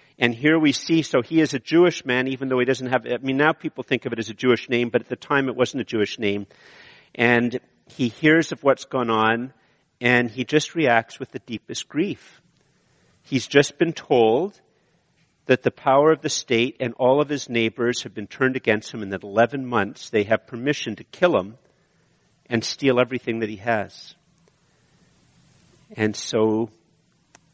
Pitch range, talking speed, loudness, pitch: 115-140 Hz, 190 wpm, -22 LUFS, 125 Hz